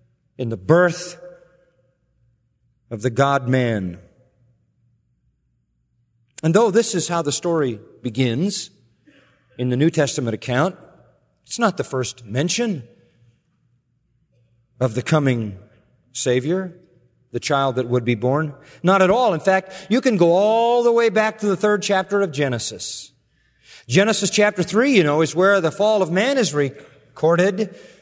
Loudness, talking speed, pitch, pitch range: -19 LUFS, 140 wpm, 140 Hz, 120-185 Hz